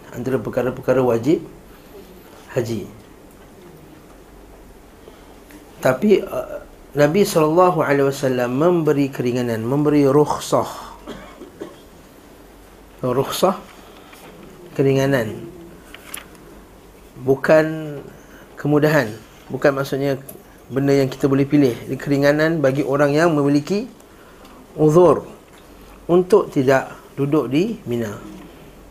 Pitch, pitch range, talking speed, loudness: 140 Hz, 130-155 Hz, 75 wpm, -18 LUFS